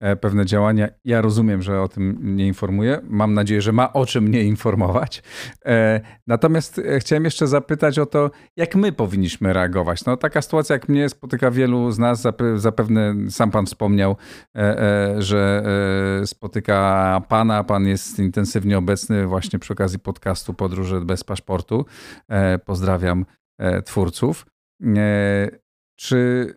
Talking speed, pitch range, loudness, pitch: 130 wpm, 95-120 Hz, -20 LUFS, 105 Hz